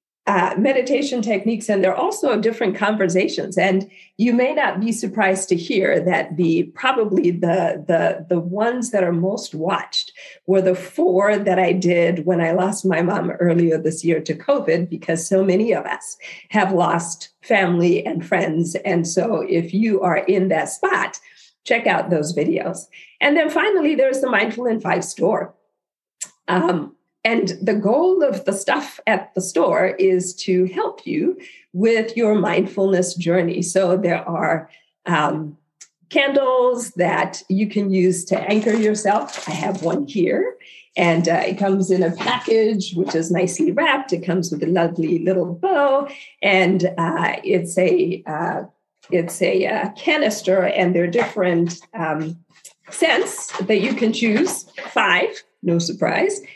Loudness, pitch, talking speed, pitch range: -19 LUFS, 190 Hz, 155 wpm, 175-225 Hz